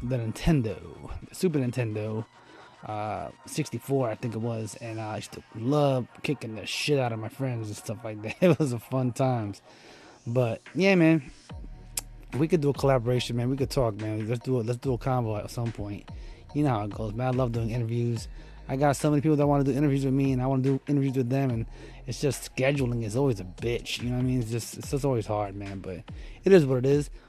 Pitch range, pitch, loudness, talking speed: 115-140 Hz, 125 Hz, -28 LUFS, 245 wpm